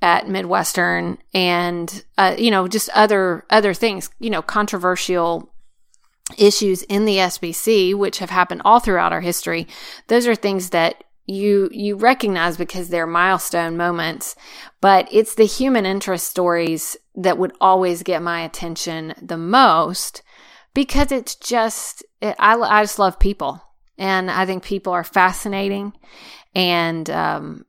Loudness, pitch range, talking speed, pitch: -18 LUFS, 175-210 Hz, 145 wpm, 190 Hz